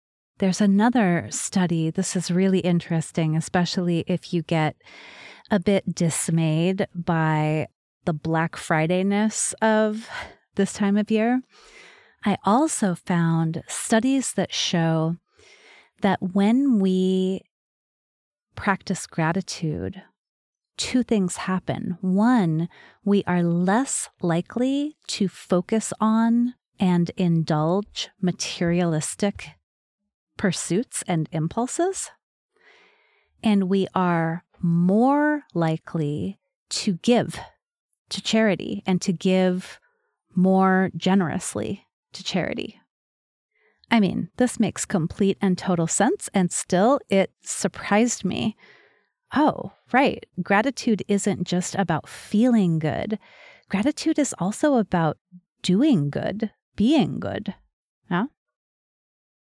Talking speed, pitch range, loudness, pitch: 100 wpm, 175-220 Hz, -23 LUFS, 190 Hz